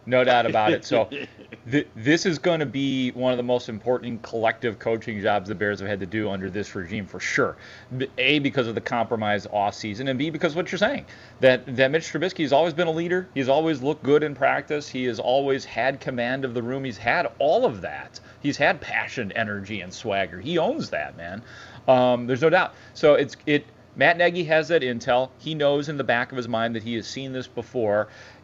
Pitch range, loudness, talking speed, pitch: 115-145 Hz, -24 LUFS, 225 wpm, 125 Hz